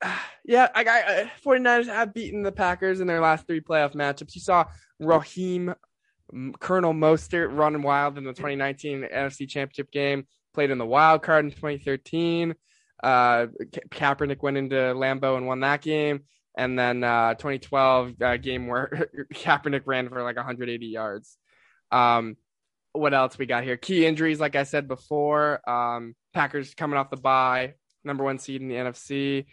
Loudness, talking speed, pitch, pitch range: -24 LUFS, 165 wpm, 140 Hz, 130-155 Hz